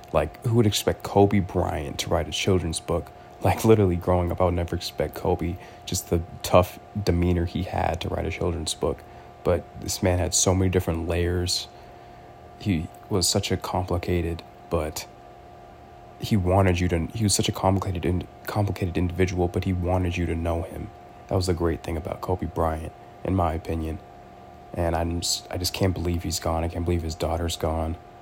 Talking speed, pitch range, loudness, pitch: 190 wpm, 85-95 Hz, -25 LUFS, 90 Hz